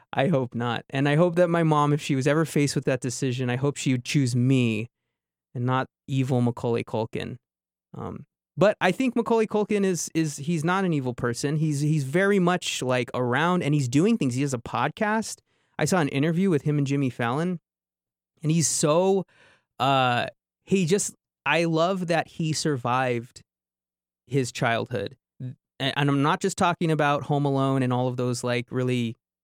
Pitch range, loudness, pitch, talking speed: 125-165 Hz, -25 LUFS, 140 Hz, 185 wpm